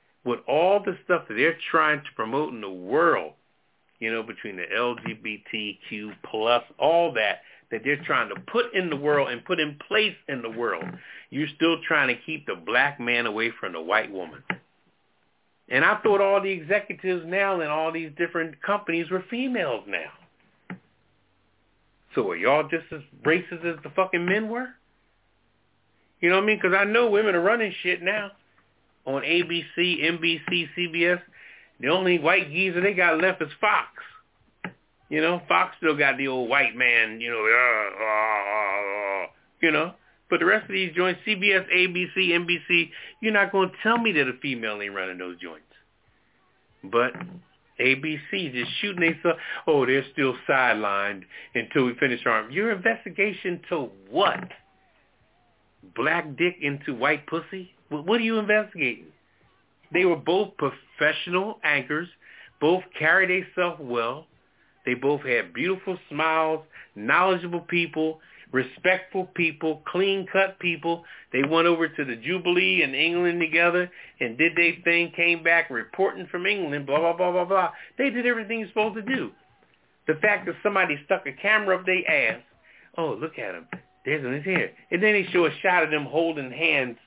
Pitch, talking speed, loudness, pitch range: 170 Hz, 165 wpm, -24 LUFS, 145-190 Hz